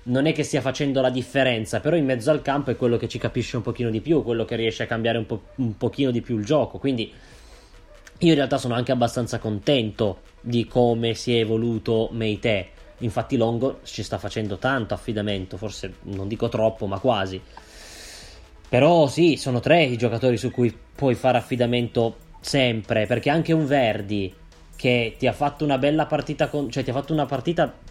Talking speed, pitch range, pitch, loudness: 195 wpm, 110-135 Hz, 120 Hz, -23 LUFS